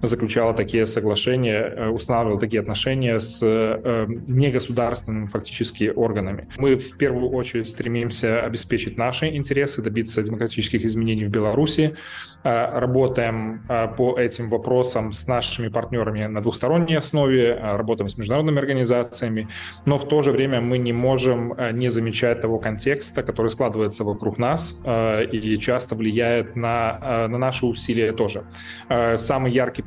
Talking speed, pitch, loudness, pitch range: 125 wpm, 115 Hz, -22 LUFS, 110-125 Hz